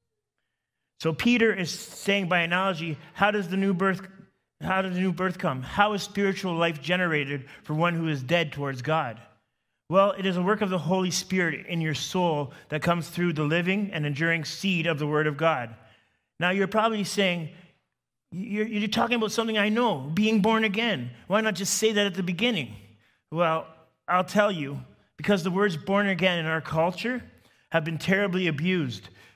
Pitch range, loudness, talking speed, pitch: 160-200 Hz, -26 LUFS, 190 wpm, 180 Hz